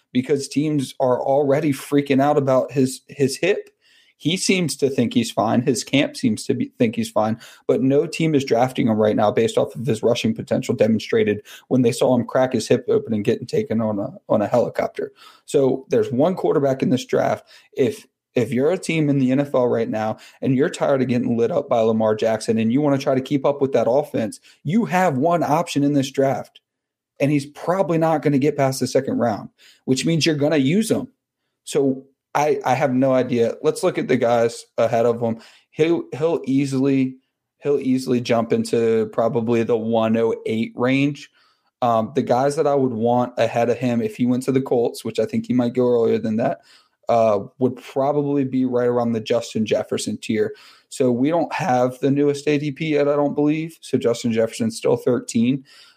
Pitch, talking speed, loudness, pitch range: 135 Hz, 210 wpm, -20 LUFS, 120-150 Hz